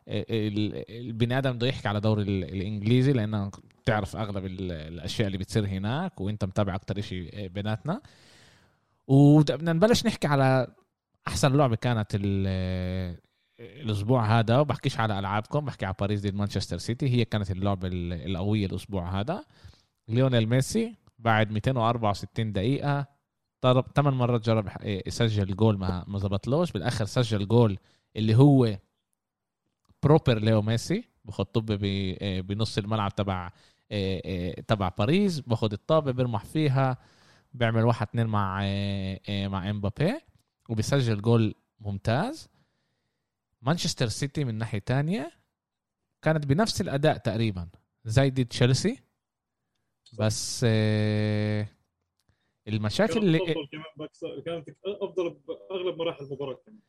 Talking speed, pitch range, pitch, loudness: 110 wpm, 100-135 Hz, 110 Hz, -27 LUFS